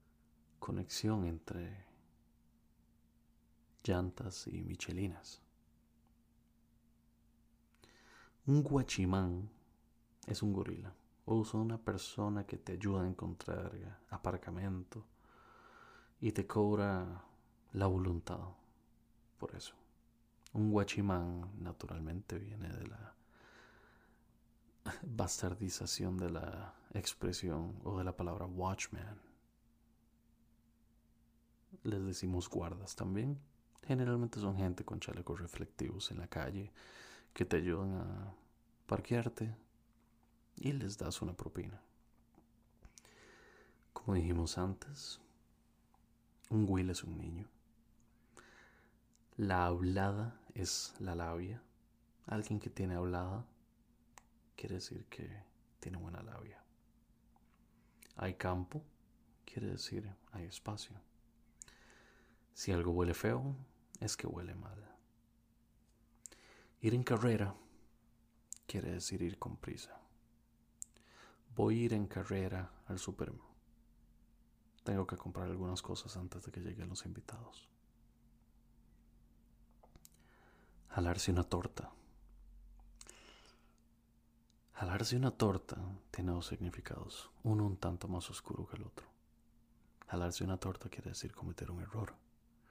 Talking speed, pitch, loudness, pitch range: 100 wpm, 105 Hz, -41 LUFS, 90-115 Hz